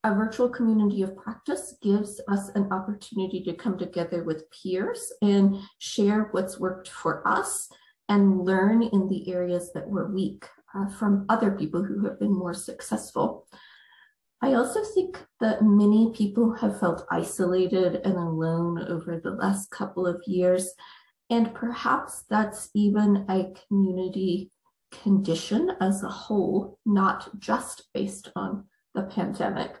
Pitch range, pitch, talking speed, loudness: 185-220 Hz, 200 Hz, 140 wpm, -26 LUFS